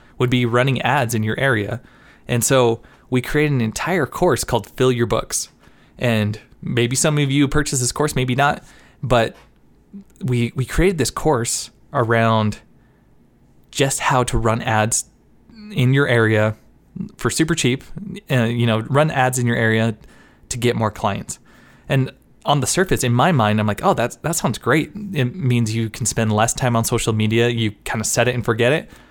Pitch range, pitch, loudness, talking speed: 115-135 Hz, 120 Hz, -19 LUFS, 185 wpm